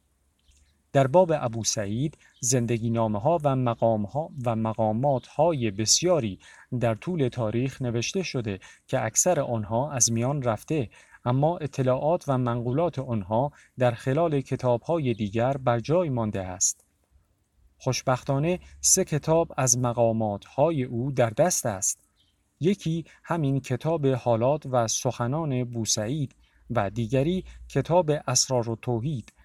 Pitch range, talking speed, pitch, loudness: 110-145 Hz, 125 wpm, 125 Hz, -26 LUFS